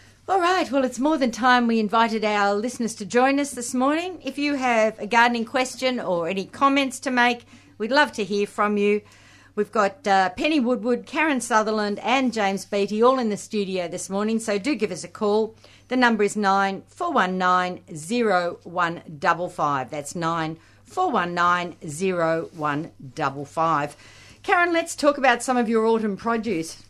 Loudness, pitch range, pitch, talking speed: -22 LUFS, 180-250 Hz, 215 Hz, 185 wpm